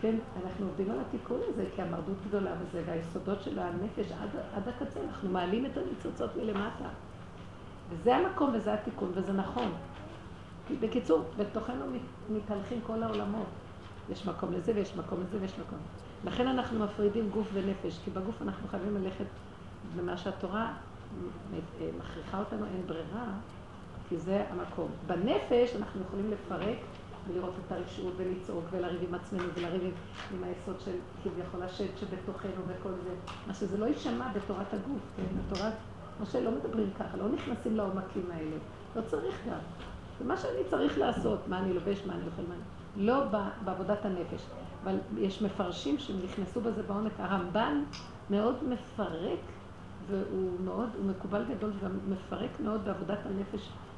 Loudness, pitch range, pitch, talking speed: -35 LUFS, 180-210 Hz, 195 Hz, 150 wpm